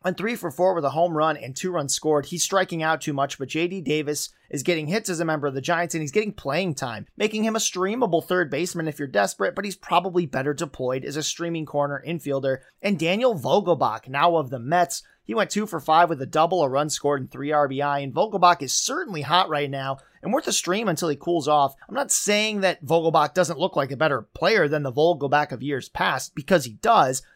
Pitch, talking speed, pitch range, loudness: 160 Hz, 240 wpm, 145-180 Hz, -23 LUFS